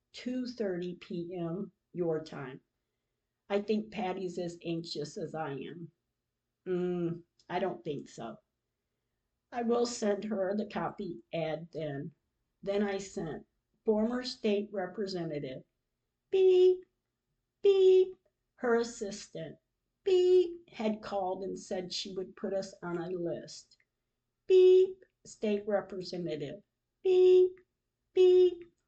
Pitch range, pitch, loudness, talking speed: 175-240 Hz, 200 Hz, -31 LUFS, 110 wpm